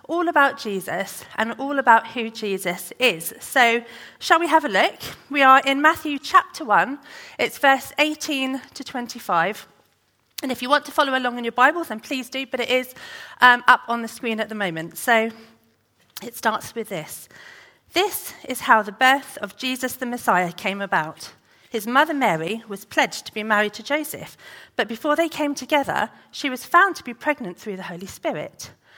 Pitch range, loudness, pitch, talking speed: 215-280 Hz, -21 LUFS, 245 Hz, 190 wpm